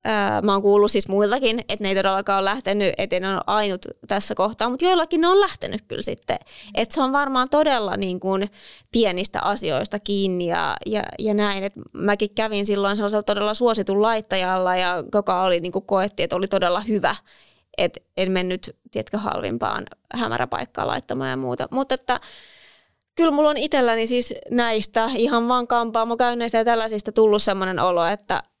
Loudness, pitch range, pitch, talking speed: -21 LUFS, 195-235 Hz, 210 Hz, 175 wpm